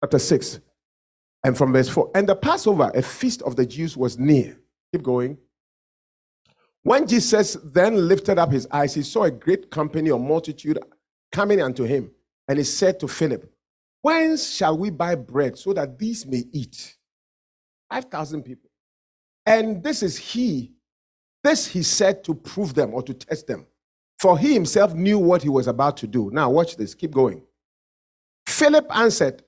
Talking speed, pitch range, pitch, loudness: 170 wpm, 130-200 Hz, 155 Hz, -21 LUFS